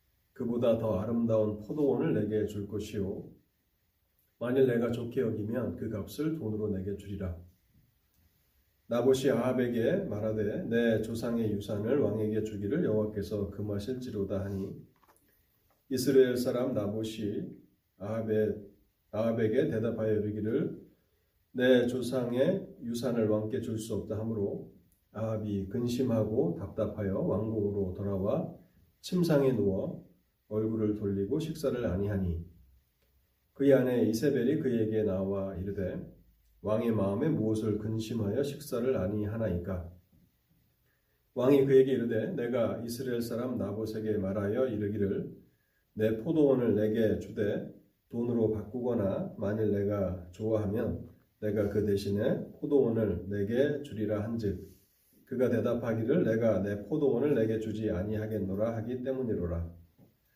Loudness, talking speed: -31 LUFS, 285 characters per minute